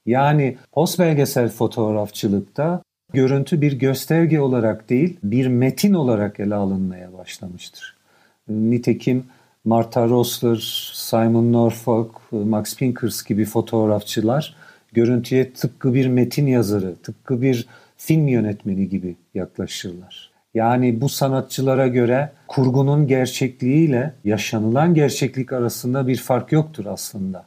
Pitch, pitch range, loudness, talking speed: 125 Hz, 110-135 Hz, -20 LUFS, 105 wpm